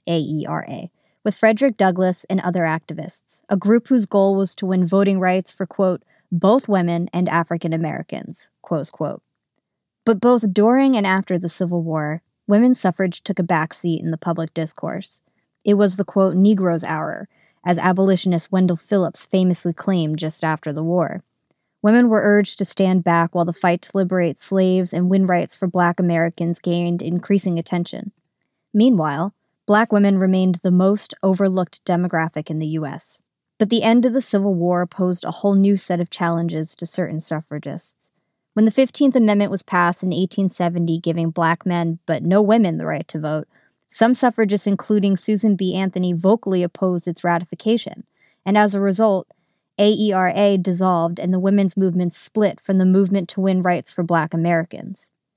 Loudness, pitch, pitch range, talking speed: -19 LUFS, 185 Hz, 170-200 Hz, 170 wpm